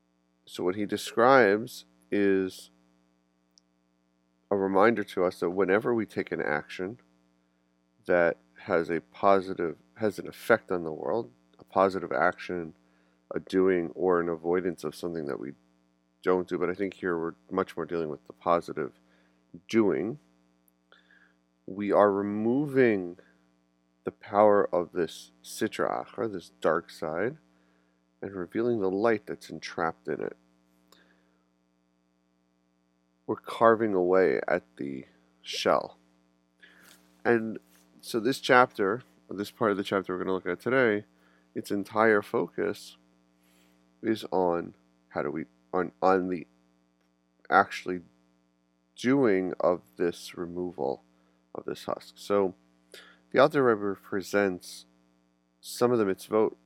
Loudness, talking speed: -28 LUFS, 125 wpm